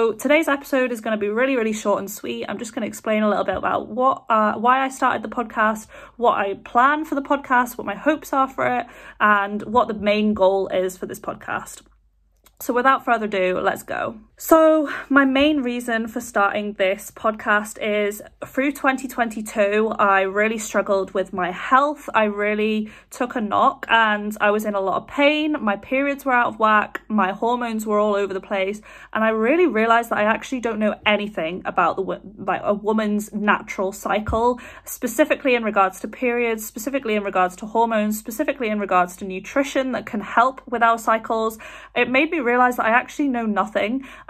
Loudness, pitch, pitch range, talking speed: -21 LUFS, 225 Hz, 205-260 Hz, 200 wpm